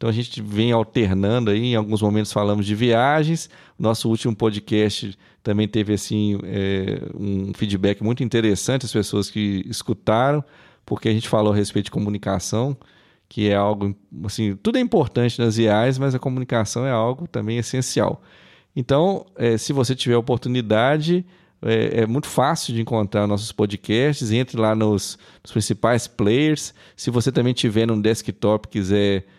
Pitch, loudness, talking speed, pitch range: 110 Hz, -21 LUFS, 165 wpm, 105-125 Hz